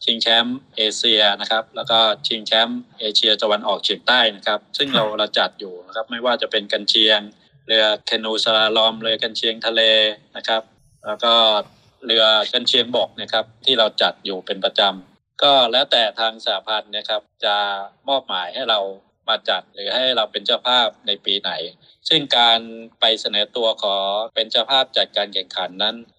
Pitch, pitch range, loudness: 110 Hz, 105-115 Hz, -18 LUFS